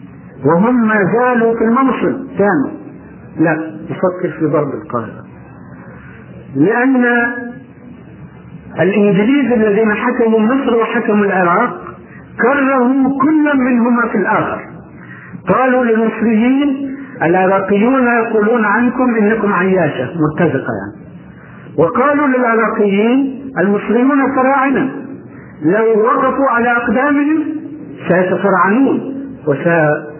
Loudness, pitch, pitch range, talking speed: -13 LUFS, 230 Hz, 195-260 Hz, 80 wpm